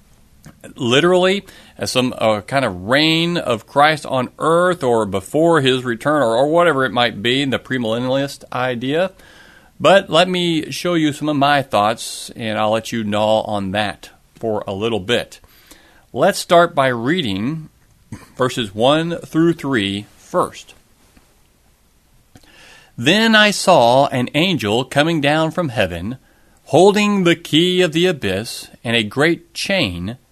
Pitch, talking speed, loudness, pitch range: 140 Hz, 145 wpm, -16 LUFS, 115-170 Hz